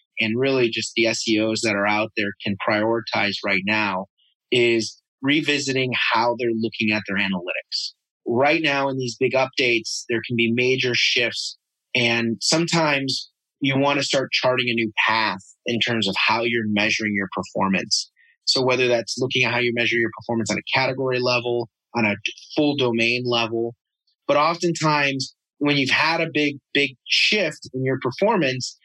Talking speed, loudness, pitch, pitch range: 170 wpm, -21 LUFS, 120 Hz, 110-130 Hz